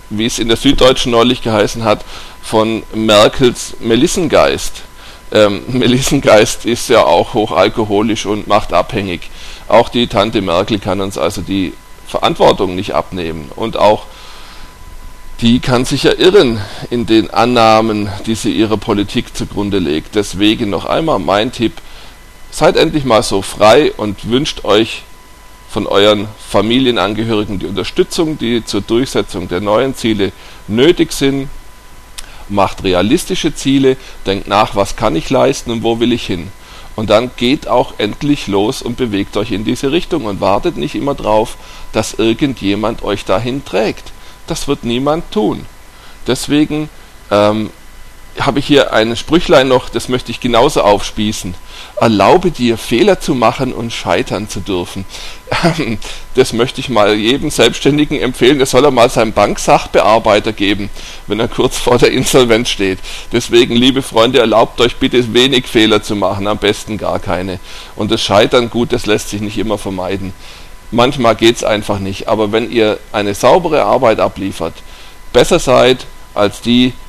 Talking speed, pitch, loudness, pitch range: 150 wpm, 110 Hz, -13 LUFS, 100-125 Hz